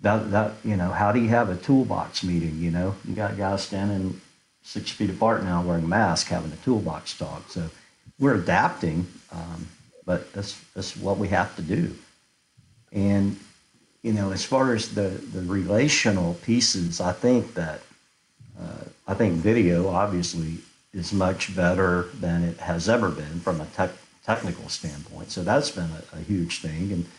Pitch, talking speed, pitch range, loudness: 95 Hz, 175 wpm, 85-105 Hz, -25 LUFS